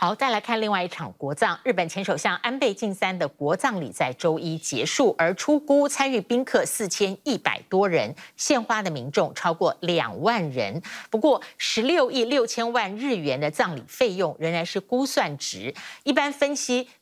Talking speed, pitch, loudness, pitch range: 270 characters per minute, 210 Hz, -24 LUFS, 170-255 Hz